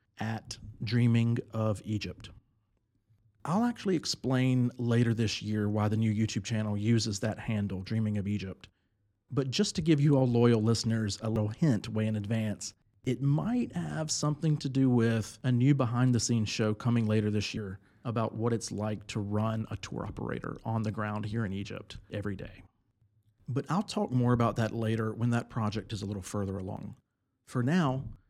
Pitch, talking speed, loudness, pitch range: 110 Hz, 180 wpm, -31 LUFS, 105-125 Hz